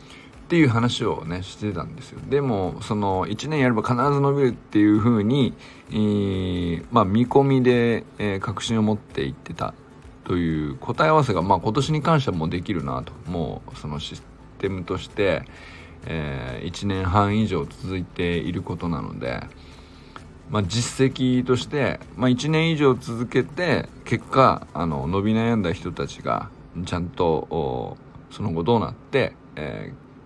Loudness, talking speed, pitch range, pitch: -23 LUFS, 295 characters per minute, 90-130 Hz, 110 Hz